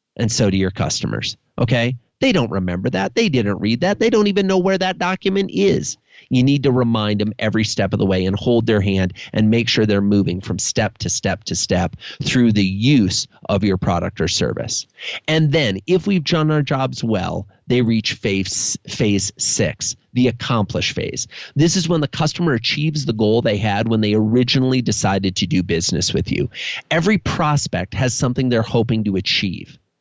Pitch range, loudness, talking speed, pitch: 105-145 Hz, -18 LUFS, 195 wpm, 115 Hz